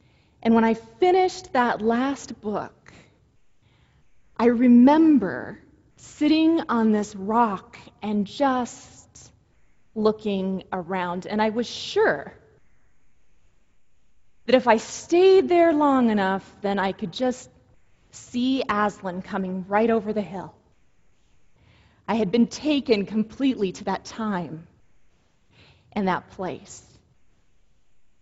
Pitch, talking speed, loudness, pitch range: 220 Hz, 105 wpm, -23 LUFS, 195-255 Hz